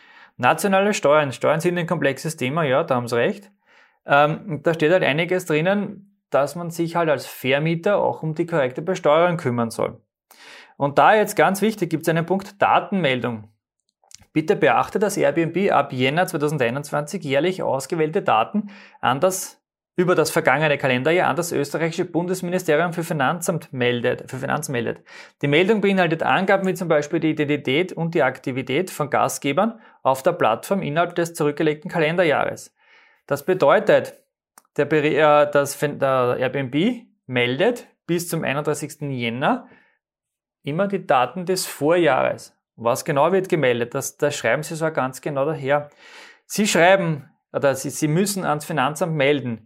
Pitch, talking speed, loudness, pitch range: 165 Hz, 150 wpm, -21 LUFS, 145-185 Hz